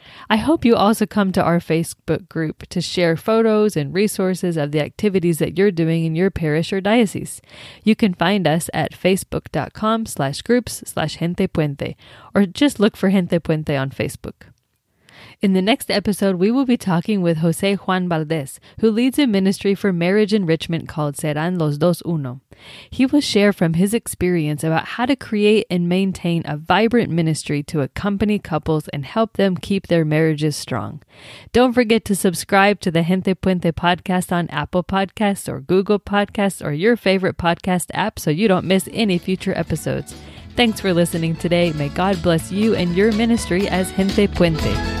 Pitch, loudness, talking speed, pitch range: 185 Hz, -19 LUFS, 180 wpm, 165-205 Hz